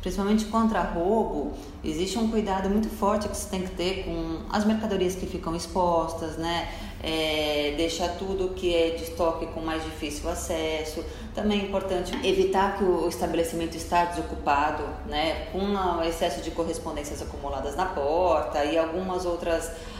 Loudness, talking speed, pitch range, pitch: -27 LUFS, 155 wpm, 165-190 Hz, 175 Hz